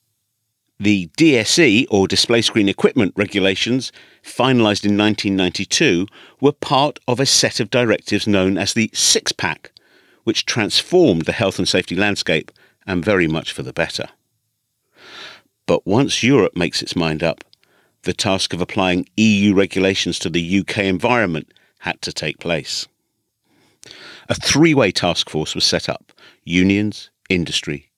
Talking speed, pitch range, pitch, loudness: 135 wpm, 95-110 Hz, 100 Hz, -17 LUFS